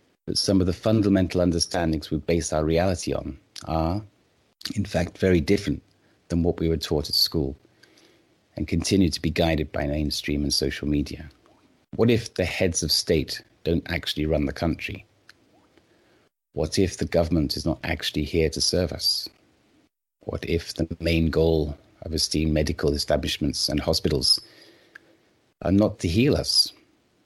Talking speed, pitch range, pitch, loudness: 155 wpm, 75-95 Hz, 85 Hz, -24 LUFS